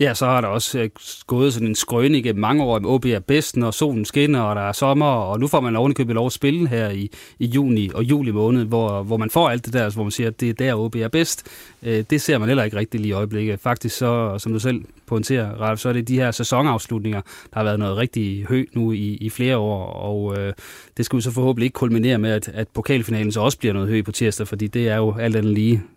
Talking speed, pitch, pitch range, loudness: 250 wpm, 115 Hz, 110-130 Hz, -20 LUFS